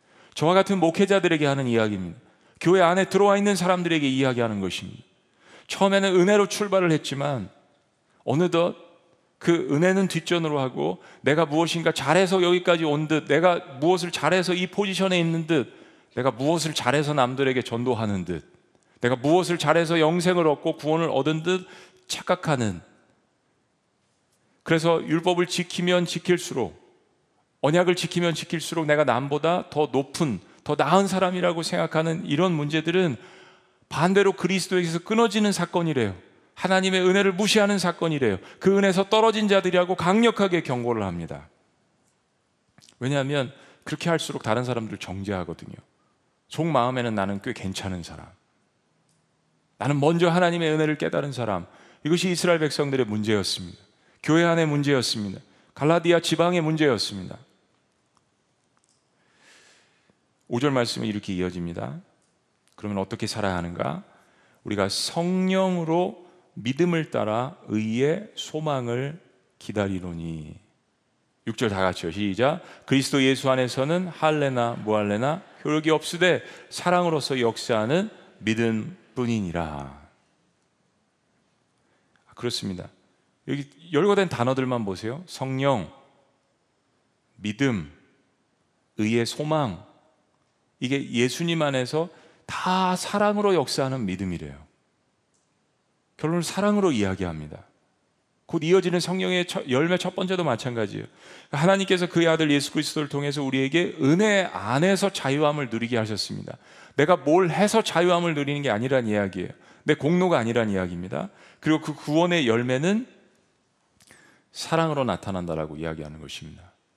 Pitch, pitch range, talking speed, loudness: 155 Hz, 120-180 Hz, 315 characters per minute, -24 LUFS